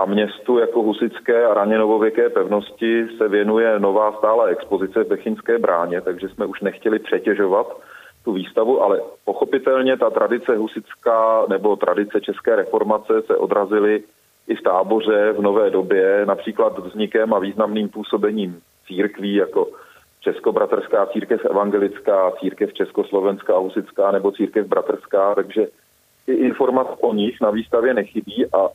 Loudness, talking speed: -19 LUFS, 135 wpm